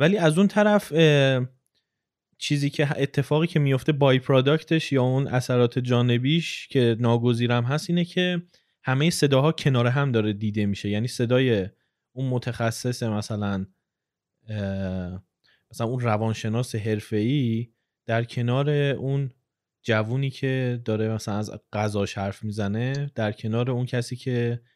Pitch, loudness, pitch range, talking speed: 125 Hz, -24 LUFS, 110-140 Hz, 125 wpm